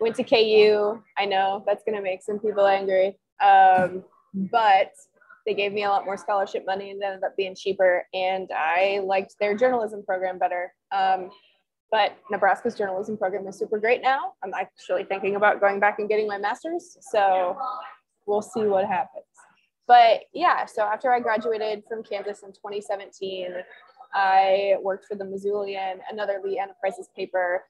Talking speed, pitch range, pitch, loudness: 165 wpm, 190-215 Hz, 200 Hz, -23 LUFS